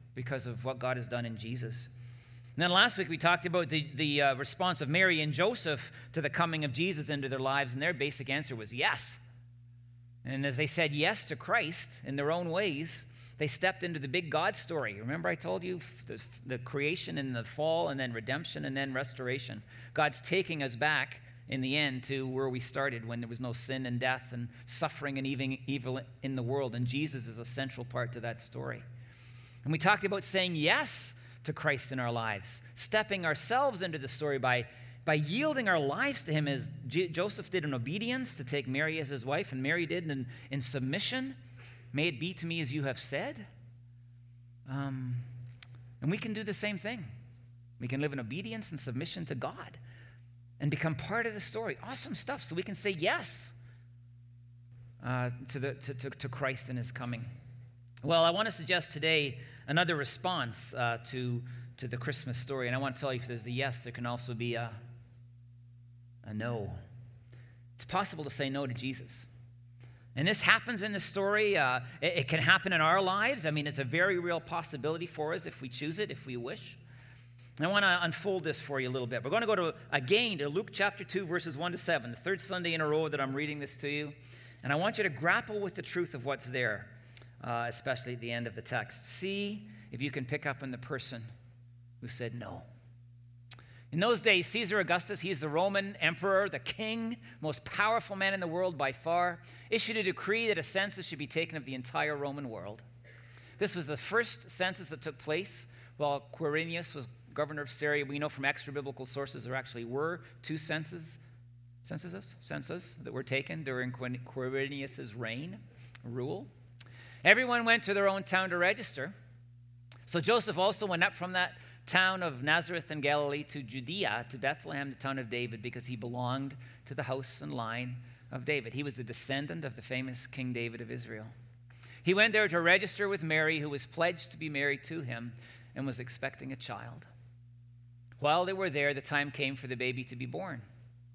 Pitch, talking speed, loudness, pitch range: 135 Hz, 205 wpm, -33 LUFS, 120-160 Hz